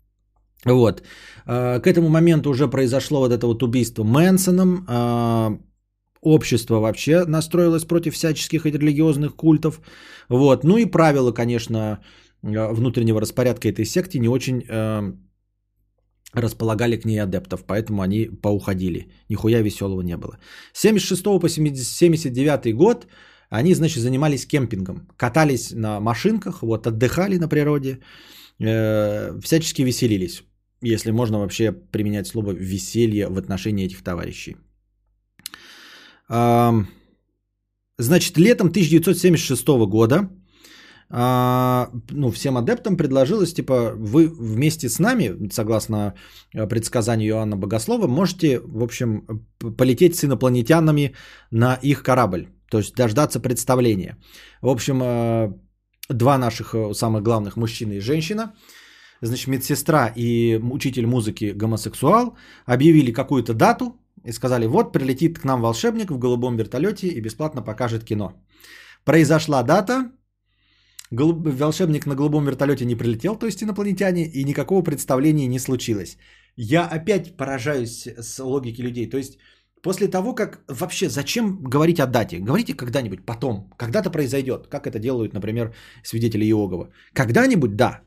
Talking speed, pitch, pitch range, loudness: 120 wpm, 125 Hz, 110-155 Hz, -20 LUFS